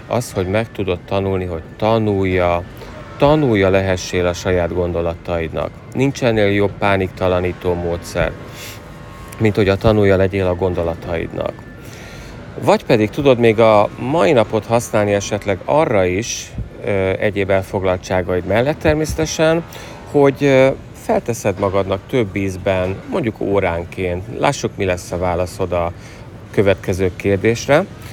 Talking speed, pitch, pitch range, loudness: 115 wpm, 100 Hz, 90-115 Hz, -17 LUFS